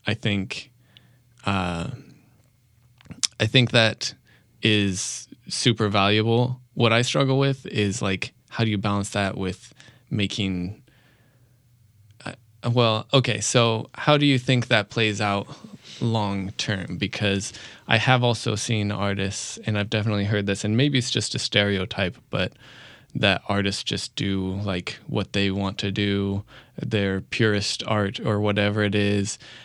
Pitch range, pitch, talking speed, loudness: 100-120 Hz, 110 Hz, 140 wpm, -23 LUFS